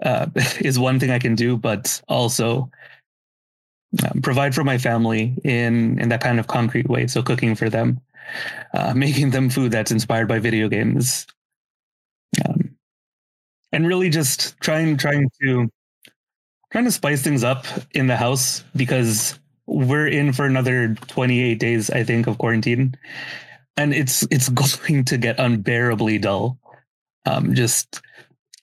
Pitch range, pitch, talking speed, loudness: 115-140 Hz, 125 Hz, 145 wpm, -20 LUFS